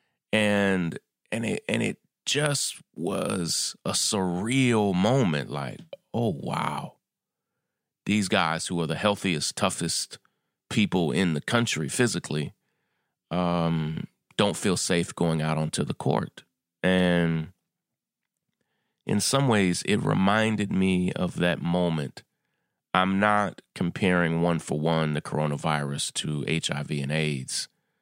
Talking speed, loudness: 120 wpm, -26 LUFS